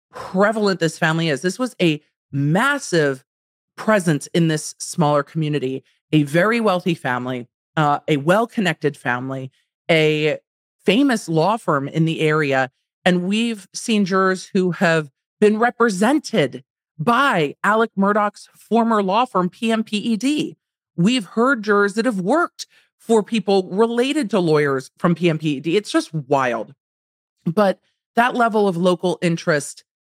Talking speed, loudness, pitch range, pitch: 130 wpm, -19 LUFS, 155-220 Hz, 180 Hz